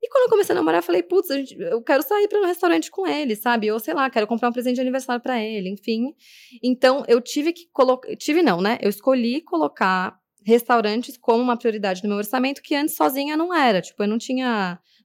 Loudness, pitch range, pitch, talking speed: -21 LUFS, 220-305 Hz, 255 Hz, 225 wpm